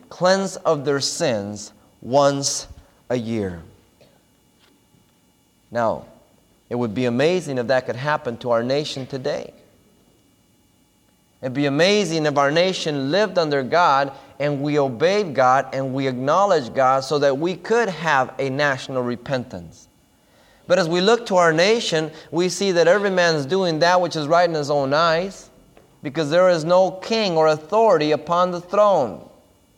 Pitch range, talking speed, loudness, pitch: 135-175 Hz, 155 wpm, -20 LUFS, 150 Hz